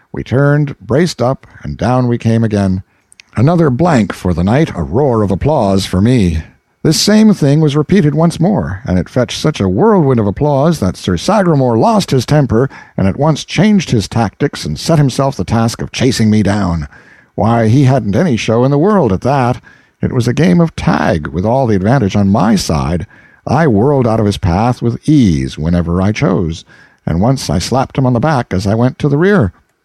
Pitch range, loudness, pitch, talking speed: 100-150 Hz, -12 LUFS, 125 Hz, 210 wpm